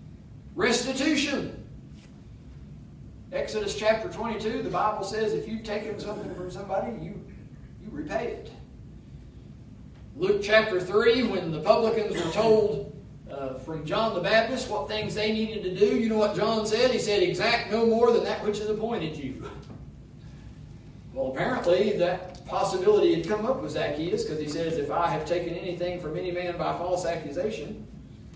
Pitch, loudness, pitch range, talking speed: 210 Hz, -27 LUFS, 175-220 Hz, 160 wpm